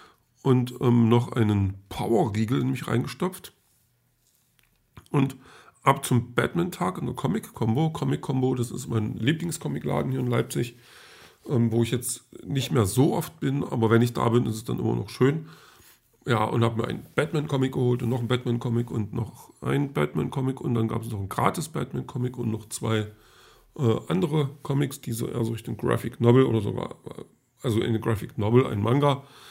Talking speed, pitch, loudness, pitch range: 190 wpm, 120 Hz, -26 LUFS, 115-135 Hz